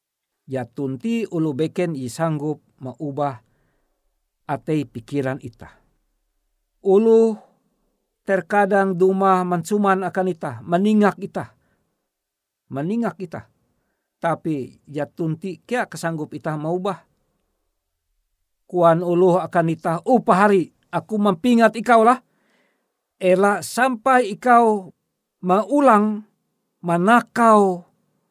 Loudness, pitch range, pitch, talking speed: -19 LUFS, 145-210 Hz, 180 Hz, 90 wpm